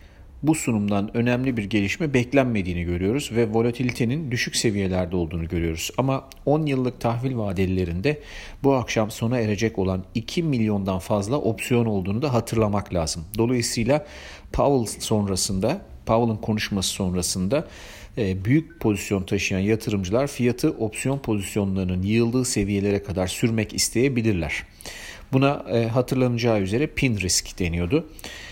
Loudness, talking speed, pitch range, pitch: -23 LUFS, 115 wpm, 95-125 Hz, 110 Hz